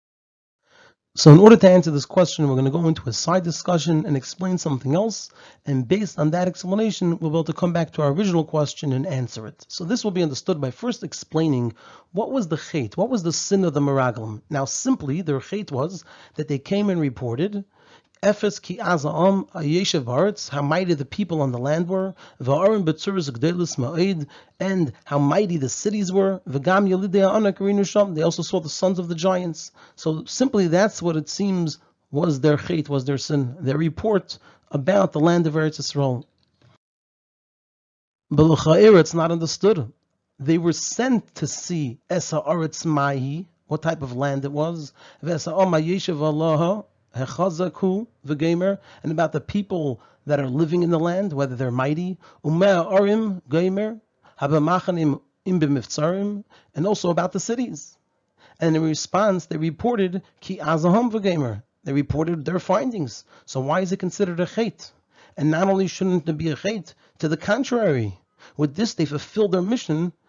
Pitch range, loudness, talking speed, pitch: 145-190 Hz, -22 LUFS, 155 wpm, 165 Hz